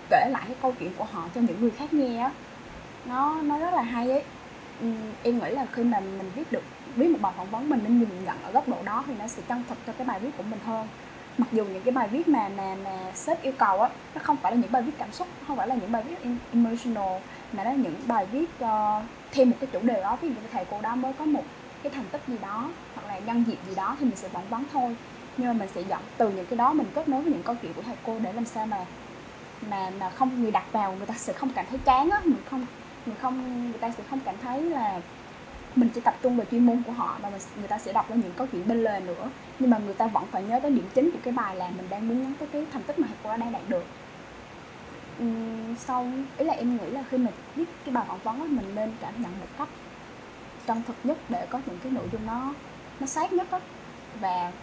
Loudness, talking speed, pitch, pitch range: -28 LUFS, 275 wpm, 245 Hz, 225-270 Hz